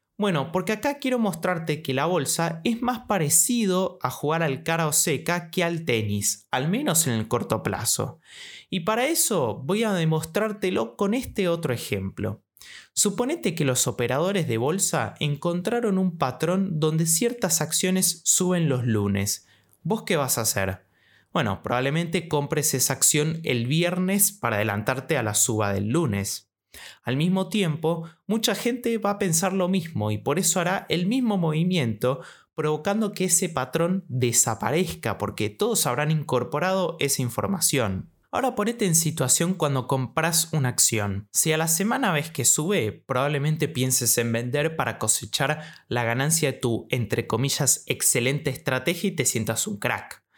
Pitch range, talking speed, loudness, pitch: 125-185 Hz, 155 wpm, -24 LUFS, 155 Hz